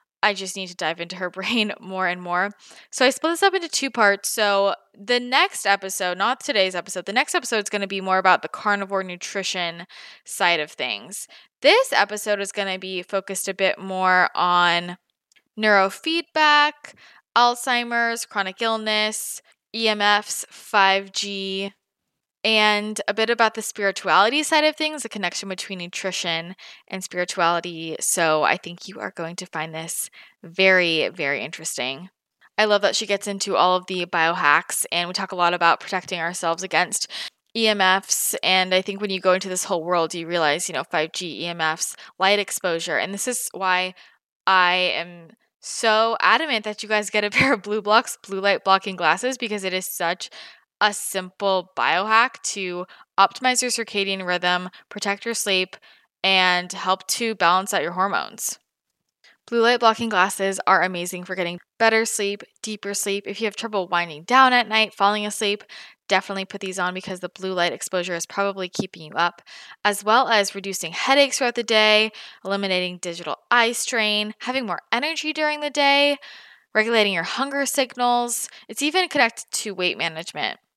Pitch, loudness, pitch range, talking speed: 195 Hz, -21 LUFS, 180-220 Hz, 170 wpm